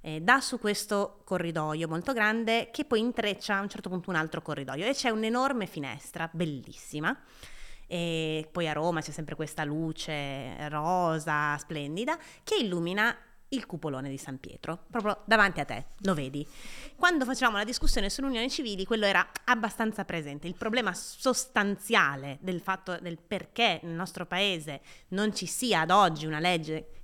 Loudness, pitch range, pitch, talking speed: -30 LUFS, 155-225 Hz, 185 Hz, 160 wpm